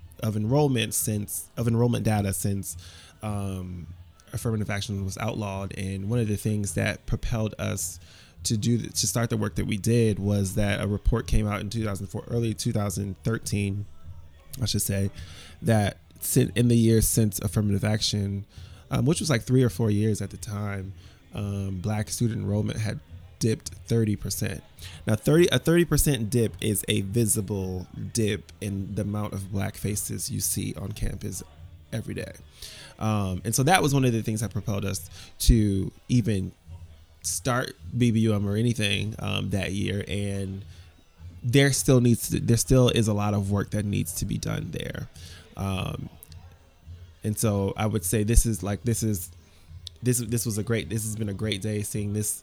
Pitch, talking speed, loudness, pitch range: 105 Hz, 175 wpm, -26 LUFS, 95-115 Hz